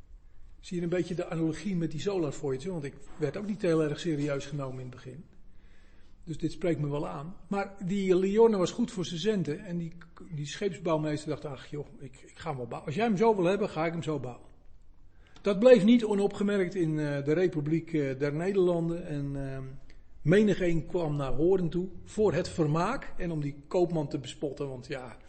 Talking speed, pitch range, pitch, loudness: 210 wpm, 145-185 Hz, 160 Hz, -30 LUFS